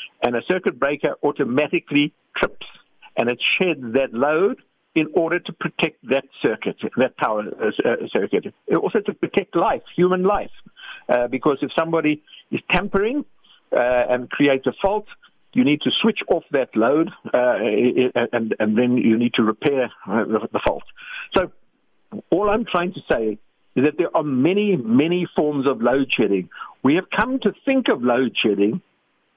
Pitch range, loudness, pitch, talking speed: 125-200 Hz, -21 LUFS, 155 Hz, 160 wpm